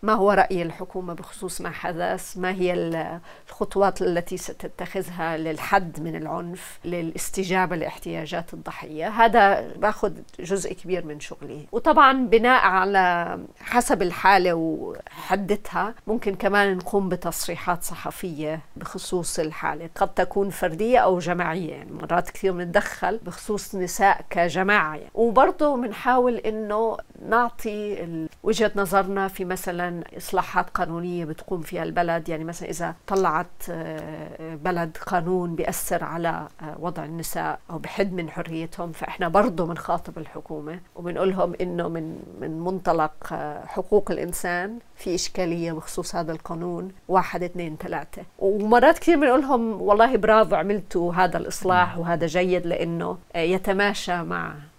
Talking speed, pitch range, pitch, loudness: 120 wpm, 170-200 Hz, 180 Hz, -24 LUFS